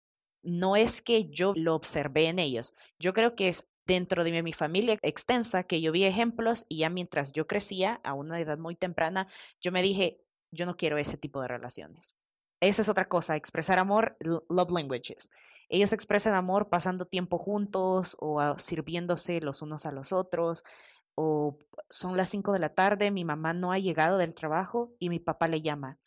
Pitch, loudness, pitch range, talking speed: 175 Hz, -28 LUFS, 160-190 Hz, 190 wpm